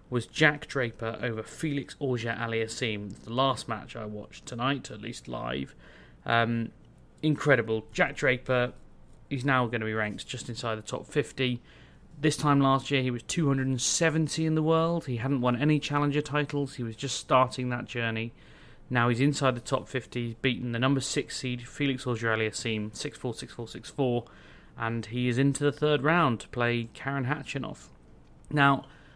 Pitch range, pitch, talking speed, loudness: 115-140 Hz, 125 Hz, 180 wpm, -29 LUFS